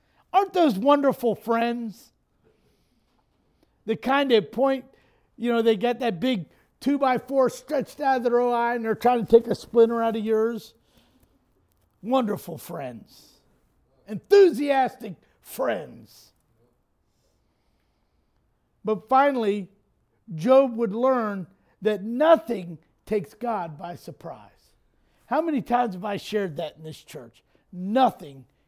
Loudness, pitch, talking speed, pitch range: -23 LUFS, 230 Hz, 125 wpm, 200-255 Hz